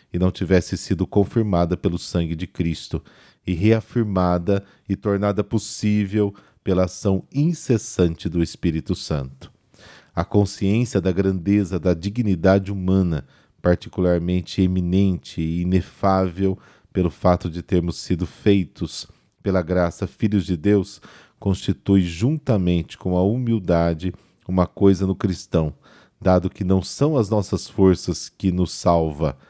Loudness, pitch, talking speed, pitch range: -21 LUFS, 95 Hz, 125 wpm, 90-100 Hz